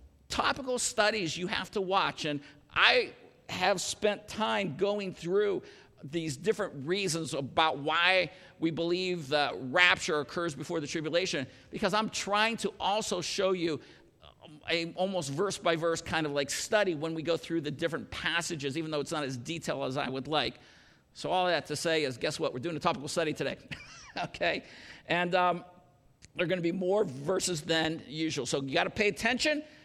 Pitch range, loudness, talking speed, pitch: 155-195 Hz, -30 LUFS, 185 wpm, 170 Hz